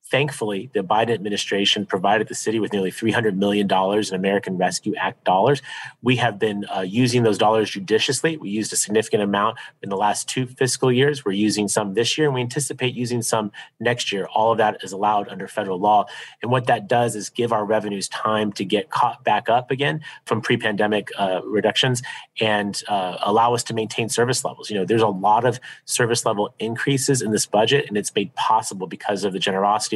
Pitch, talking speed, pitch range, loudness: 110 Hz, 205 wpm, 105-120 Hz, -21 LUFS